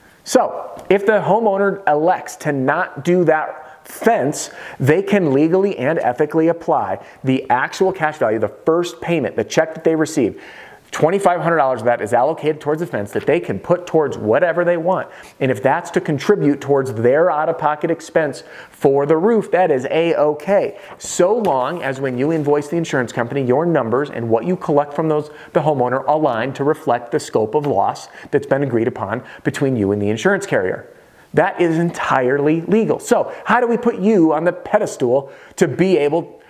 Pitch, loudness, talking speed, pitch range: 155 Hz, -17 LUFS, 185 wpm, 140-185 Hz